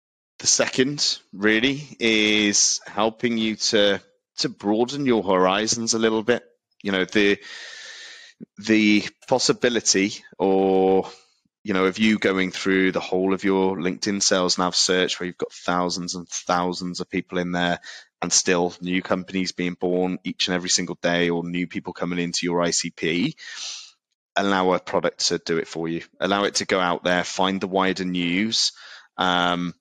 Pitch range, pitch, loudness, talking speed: 90-105 Hz, 95 Hz, -22 LUFS, 165 wpm